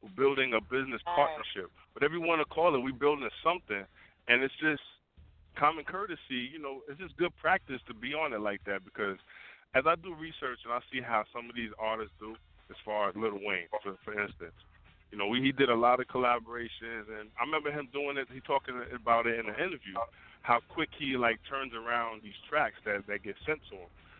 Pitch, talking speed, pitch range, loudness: 120 Hz, 220 wpm, 110-140 Hz, -32 LUFS